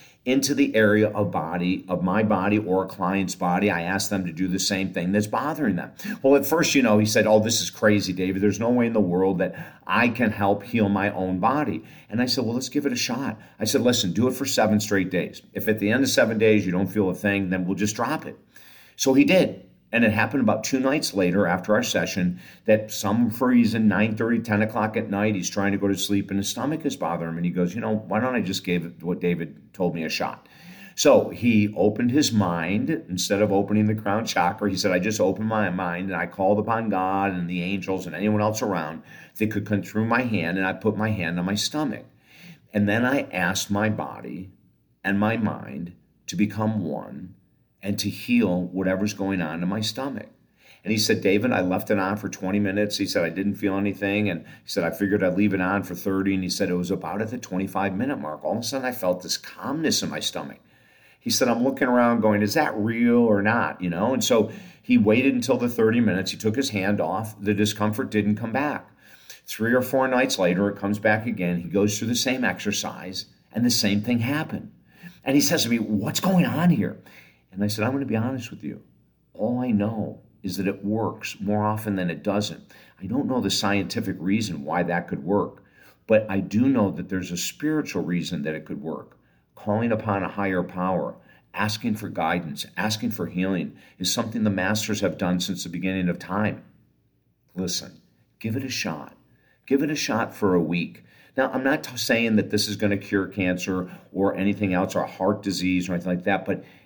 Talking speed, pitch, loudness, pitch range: 230 wpm, 105 Hz, -24 LUFS, 95-110 Hz